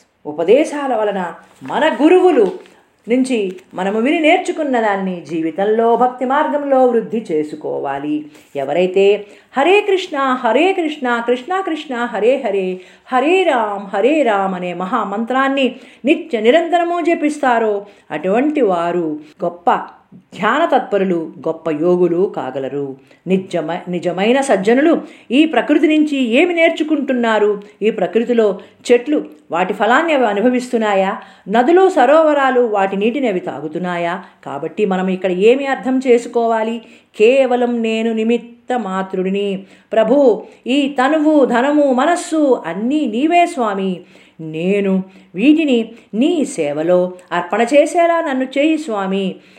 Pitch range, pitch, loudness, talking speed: 190-275 Hz, 230 Hz, -15 LUFS, 105 wpm